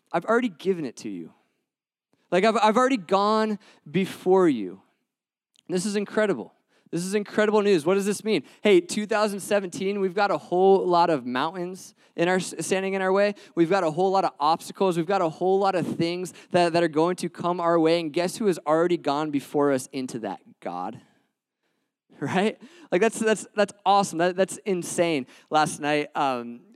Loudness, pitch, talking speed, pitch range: -24 LUFS, 190 Hz, 190 wpm, 170-205 Hz